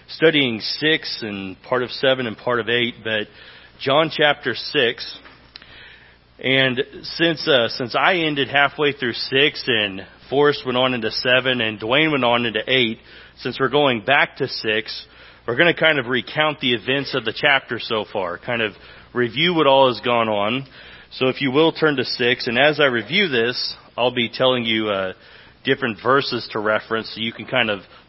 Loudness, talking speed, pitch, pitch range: -19 LUFS, 190 wpm, 125 Hz, 115-140 Hz